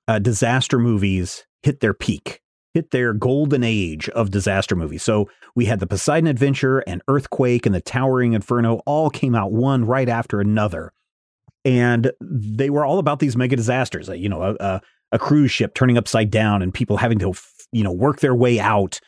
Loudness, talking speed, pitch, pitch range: -19 LUFS, 190 wpm, 120 Hz, 105-130 Hz